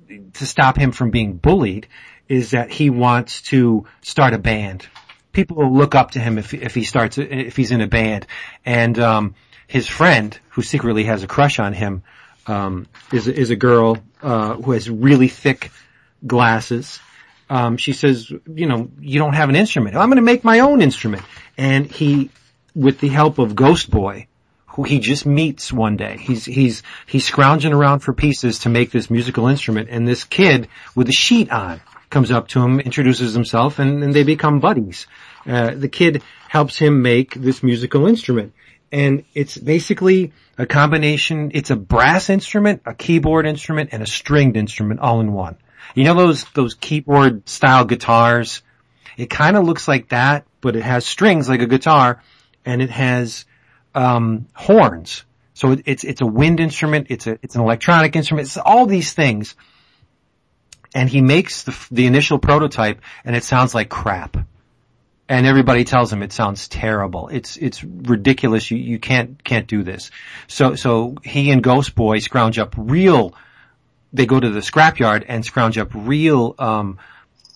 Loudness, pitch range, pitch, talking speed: -16 LUFS, 115-145 Hz, 130 Hz, 175 wpm